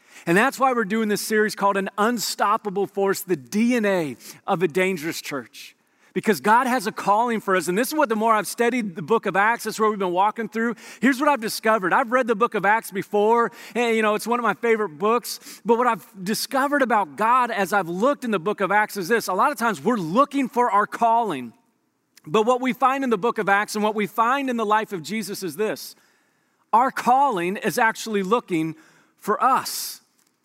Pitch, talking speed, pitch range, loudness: 220 Hz, 225 wpm, 200-235 Hz, -22 LUFS